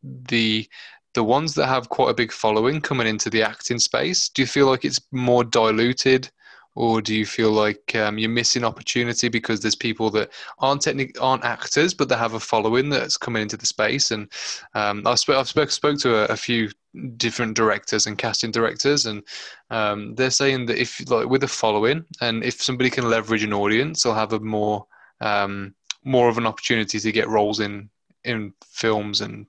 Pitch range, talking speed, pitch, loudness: 110-130 Hz, 195 wpm, 115 Hz, -21 LUFS